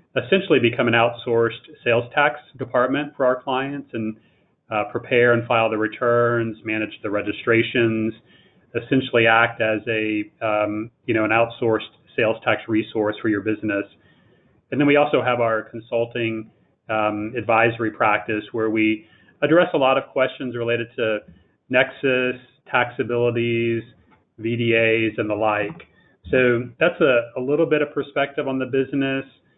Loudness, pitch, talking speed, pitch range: -21 LUFS, 115 Hz, 145 wpm, 110-125 Hz